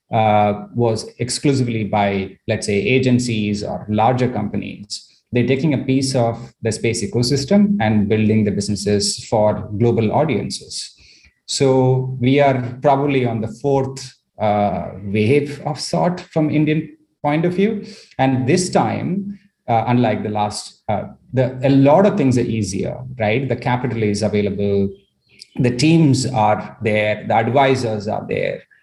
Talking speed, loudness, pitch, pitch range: 145 wpm, -18 LUFS, 120 Hz, 105-140 Hz